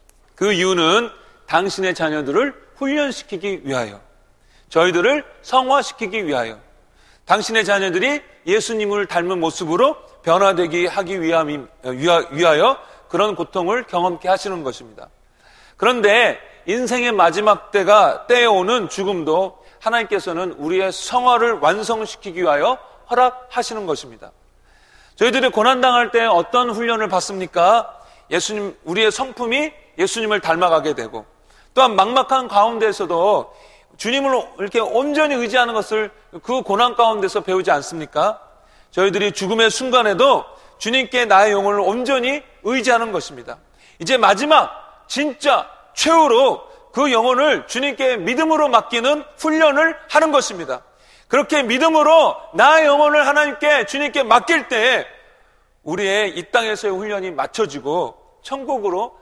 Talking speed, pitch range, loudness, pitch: 305 characters per minute, 190-270 Hz, -17 LUFS, 225 Hz